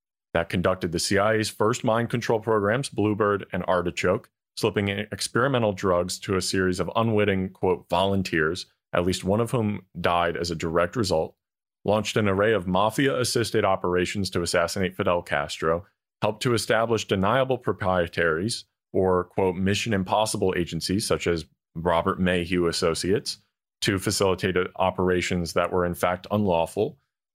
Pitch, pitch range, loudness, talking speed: 95 Hz, 90-105 Hz, -25 LUFS, 145 wpm